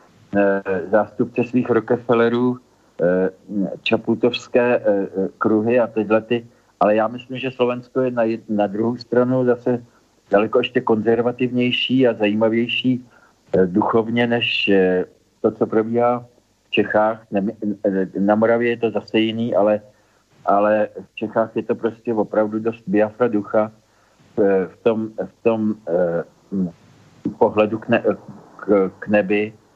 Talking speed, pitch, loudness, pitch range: 115 wpm, 110 Hz, -20 LUFS, 105-120 Hz